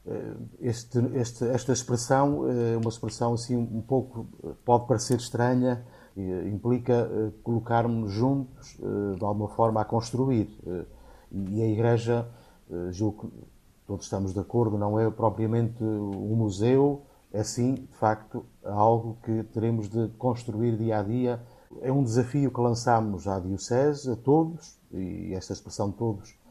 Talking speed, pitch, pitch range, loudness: 135 wpm, 115 Hz, 105-125 Hz, -28 LUFS